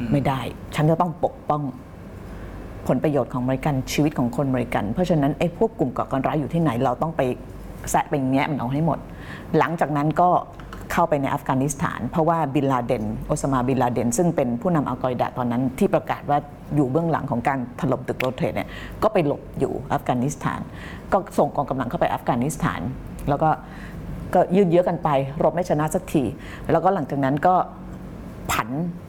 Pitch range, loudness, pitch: 125-165 Hz, -23 LUFS, 140 Hz